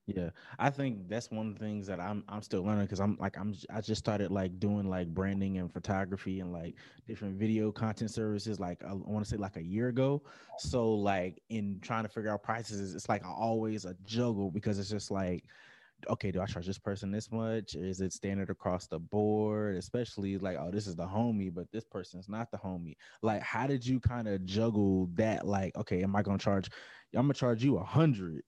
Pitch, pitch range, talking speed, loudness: 105 Hz, 95-110 Hz, 220 wpm, -35 LUFS